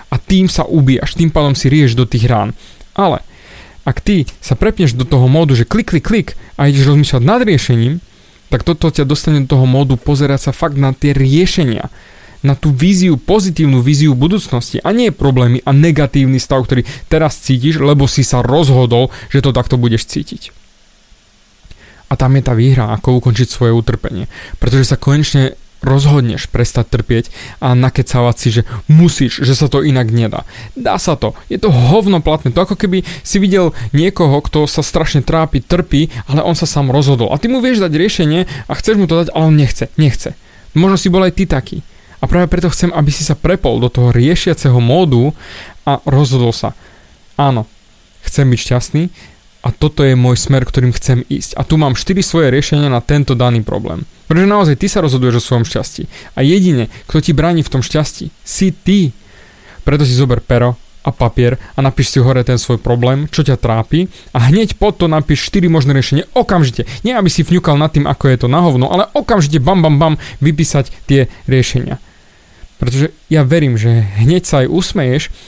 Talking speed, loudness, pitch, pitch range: 190 wpm, -12 LUFS, 140 Hz, 125-160 Hz